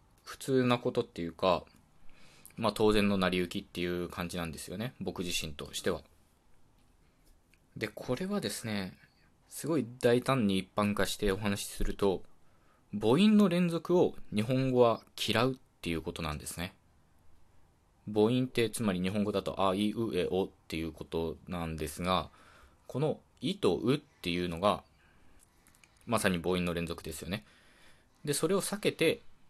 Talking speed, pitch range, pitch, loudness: 290 characters per minute, 85-115 Hz, 95 Hz, -32 LUFS